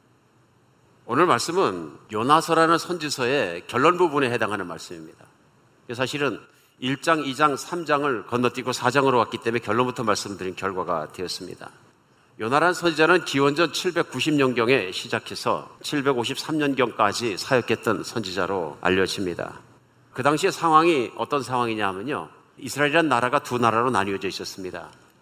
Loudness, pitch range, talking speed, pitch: -23 LUFS, 115-155 Hz, 325 characters per minute, 135 Hz